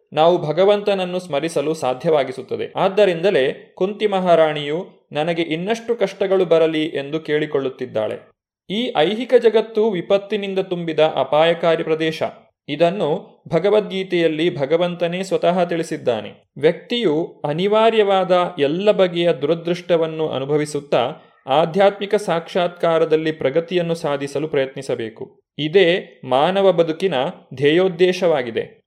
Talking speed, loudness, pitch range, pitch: 85 wpm, -19 LUFS, 155-195 Hz, 170 Hz